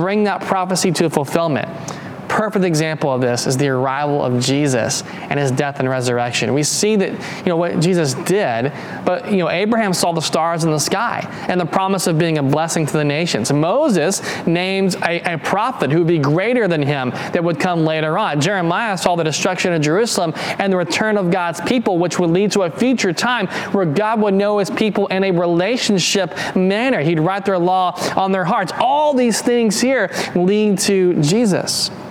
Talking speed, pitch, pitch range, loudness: 200 wpm, 180 Hz, 160-200 Hz, -17 LUFS